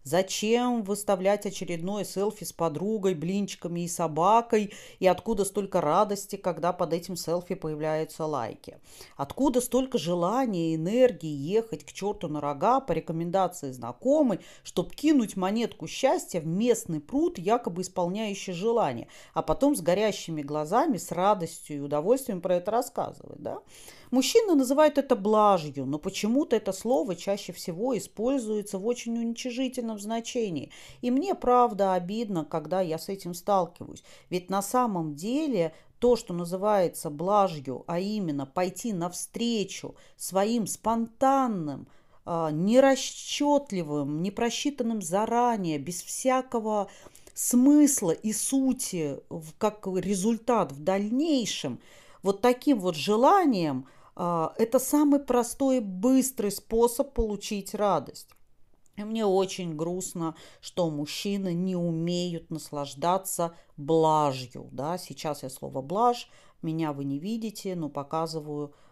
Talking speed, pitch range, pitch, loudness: 120 wpm, 170-235 Hz, 195 Hz, -27 LUFS